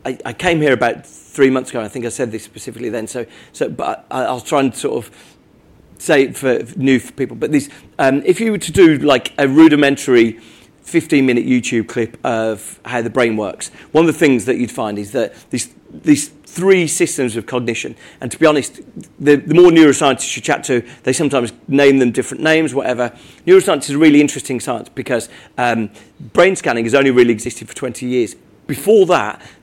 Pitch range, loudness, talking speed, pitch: 120-150 Hz, -15 LUFS, 205 wpm, 130 Hz